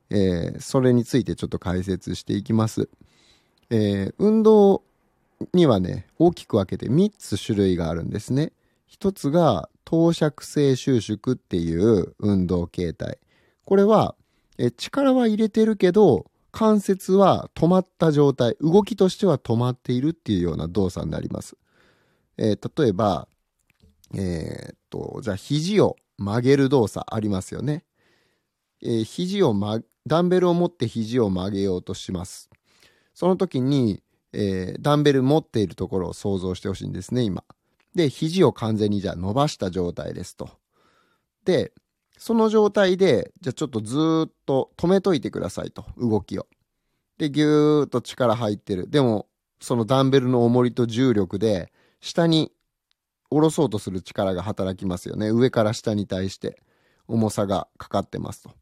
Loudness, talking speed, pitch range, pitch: -22 LUFS, 300 characters per minute, 100-160 Hz, 120 Hz